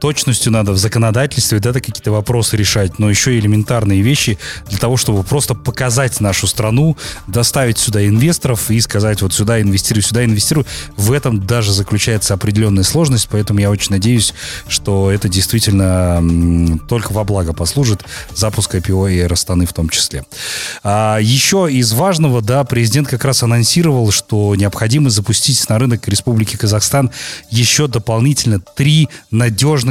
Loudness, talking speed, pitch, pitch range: -13 LUFS, 150 wpm, 110 Hz, 100-125 Hz